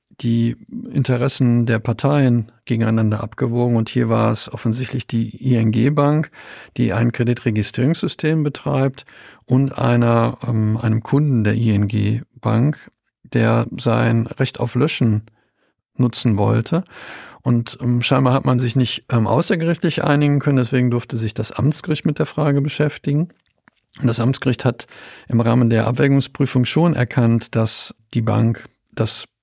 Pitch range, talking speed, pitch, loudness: 115-140 Hz, 135 wpm, 125 Hz, -18 LUFS